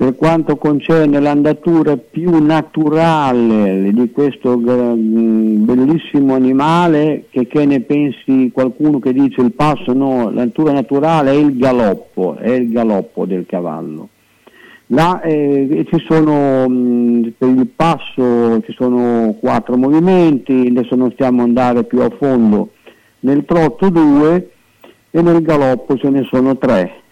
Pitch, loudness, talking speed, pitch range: 135 Hz, -13 LUFS, 125 wpm, 125-150 Hz